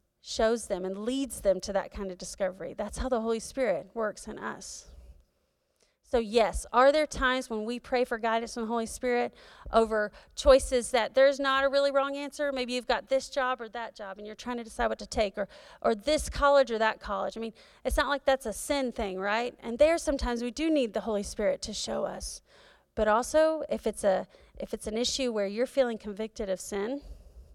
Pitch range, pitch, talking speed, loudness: 215-270 Hz, 240 Hz, 220 wpm, -29 LUFS